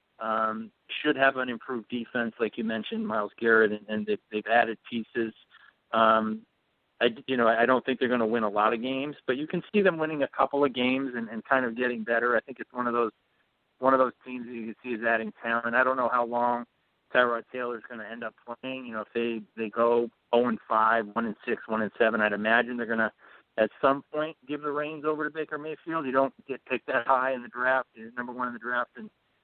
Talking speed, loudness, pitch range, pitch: 255 wpm, -28 LUFS, 110-130 Hz, 120 Hz